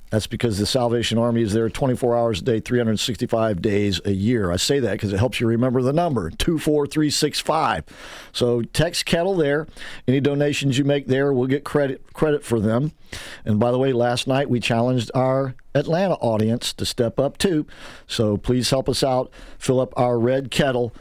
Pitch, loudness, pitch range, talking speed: 125 Hz, -21 LUFS, 115-140 Hz, 190 wpm